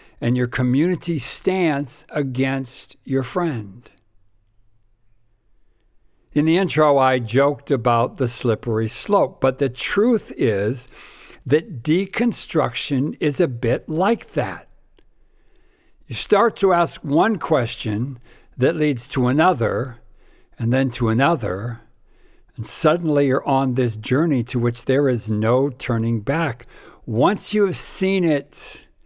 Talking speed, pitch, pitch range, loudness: 120 wpm, 135 Hz, 120-155 Hz, -20 LUFS